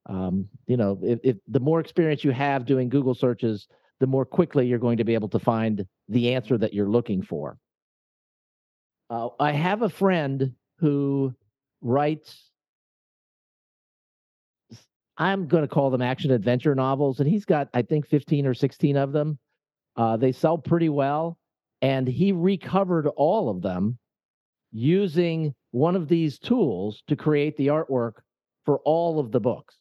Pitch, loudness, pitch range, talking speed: 135 Hz, -24 LUFS, 120-155 Hz, 160 wpm